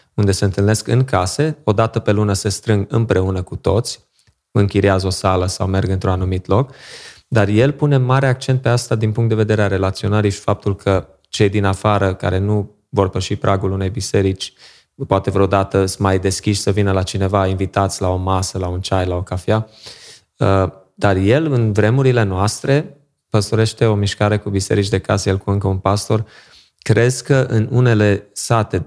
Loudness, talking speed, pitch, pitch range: -17 LUFS, 185 wpm, 100 Hz, 95-110 Hz